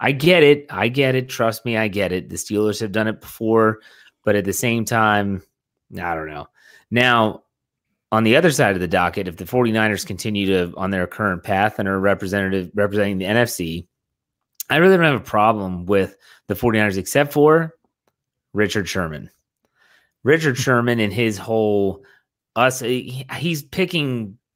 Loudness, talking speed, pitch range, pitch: -19 LUFS, 170 wpm, 100-125 Hz, 110 Hz